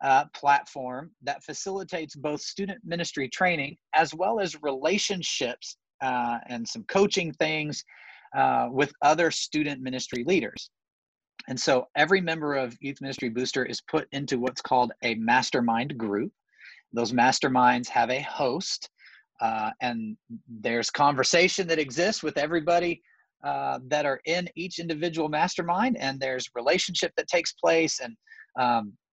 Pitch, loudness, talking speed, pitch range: 150 Hz, -26 LUFS, 140 wpm, 130-175 Hz